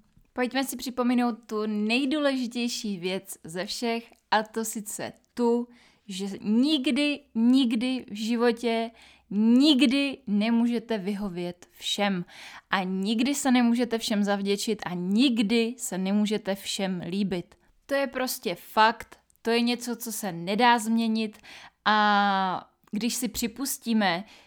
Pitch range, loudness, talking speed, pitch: 205-245 Hz, -26 LUFS, 120 wpm, 225 Hz